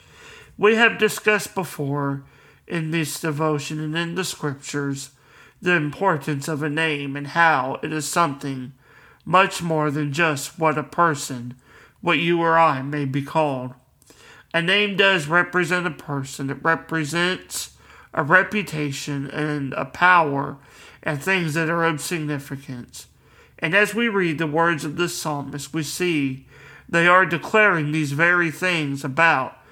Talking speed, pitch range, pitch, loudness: 145 wpm, 145-175 Hz, 155 Hz, -21 LUFS